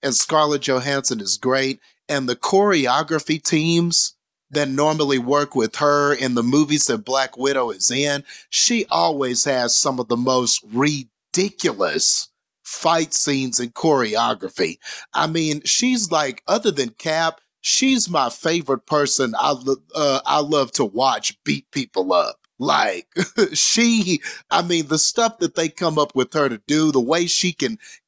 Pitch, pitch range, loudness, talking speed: 150 Hz, 135-170 Hz, -19 LUFS, 155 wpm